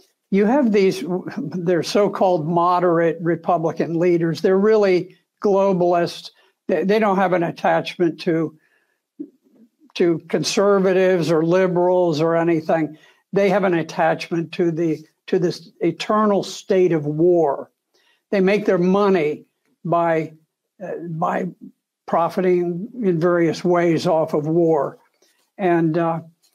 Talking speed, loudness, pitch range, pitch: 115 wpm, -19 LUFS, 165-195 Hz, 175 Hz